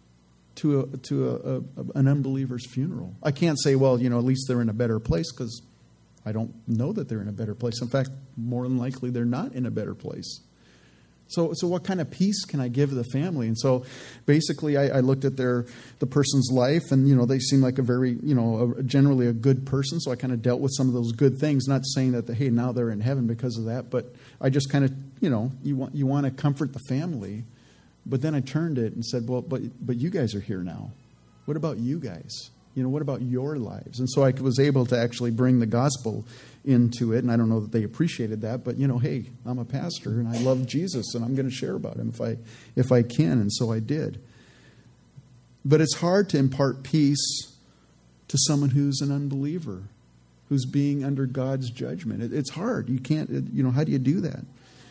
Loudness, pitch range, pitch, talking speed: -25 LUFS, 120-140 Hz, 130 Hz, 235 wpm